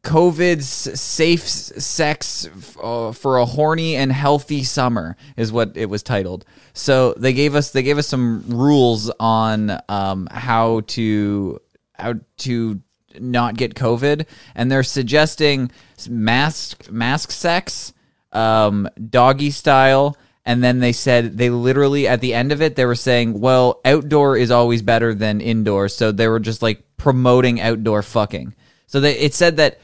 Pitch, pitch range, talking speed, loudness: 125 Hz, 115-140 Hz, 150 wpm, -17 LUFS